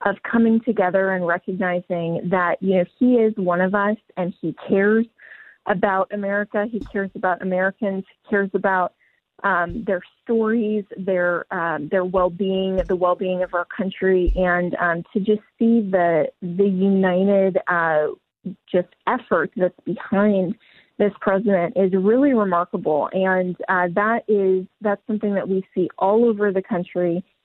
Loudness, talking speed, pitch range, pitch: -21 LUFS, 150 wpm, 180-210 Hz, 190 Hz